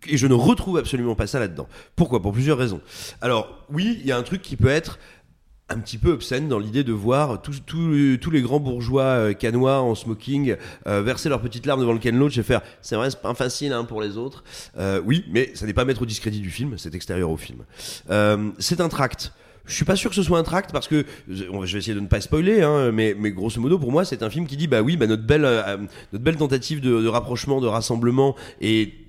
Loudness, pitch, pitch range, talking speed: -22 LUFS, 125 Hz, 110-145 Hz, 255 wpm